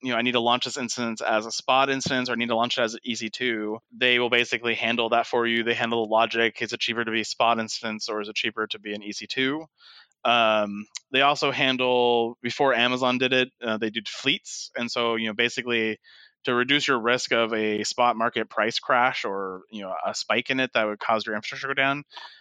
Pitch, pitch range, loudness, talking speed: 115 Hz, 110-125 Hz, -24 LUFS, 240 wpm